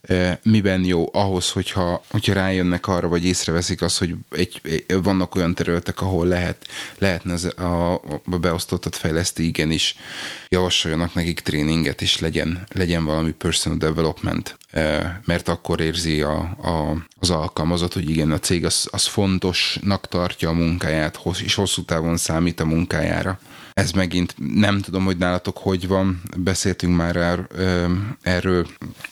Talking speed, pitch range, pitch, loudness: 140 wpm, 80-95 Hz, 90 Hz, -21 LUFS